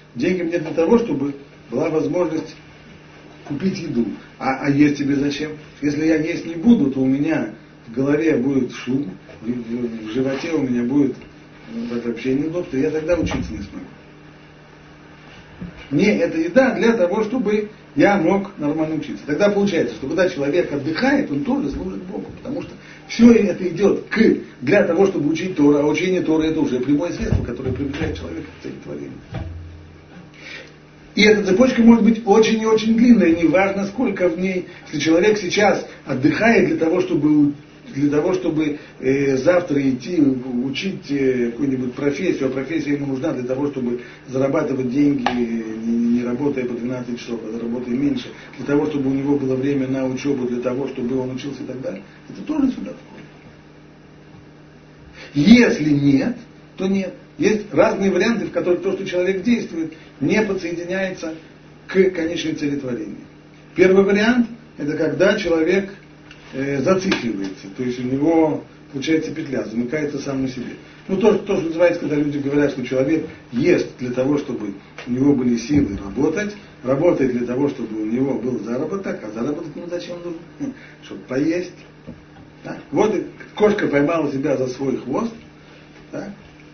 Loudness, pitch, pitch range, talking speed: -19 LUFS, 150 Hz, 130-185 Hz, 160 wpm